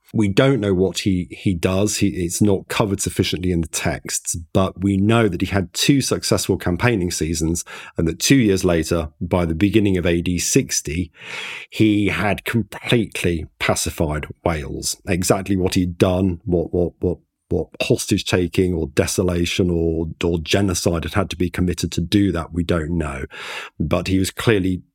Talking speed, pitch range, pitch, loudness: 170 wpm, 85-100 Hz, 90 Hz, -20 LUFS